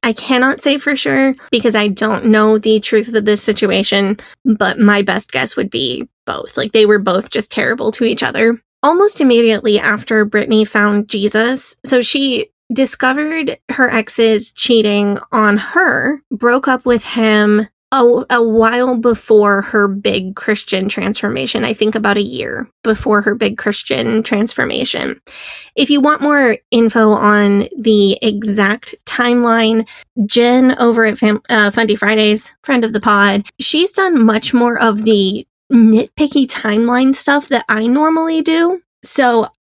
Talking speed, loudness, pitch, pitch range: 150 wpm, -13 LUFS, 225 Hz, 210-250 Hz